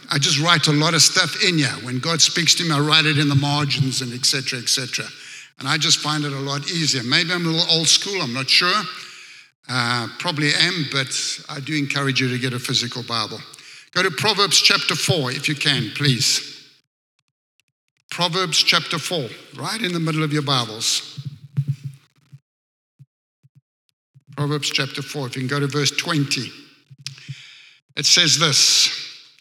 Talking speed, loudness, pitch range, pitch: 180 wpm, -18 LUFS, 135-160 Hz, 145 Hz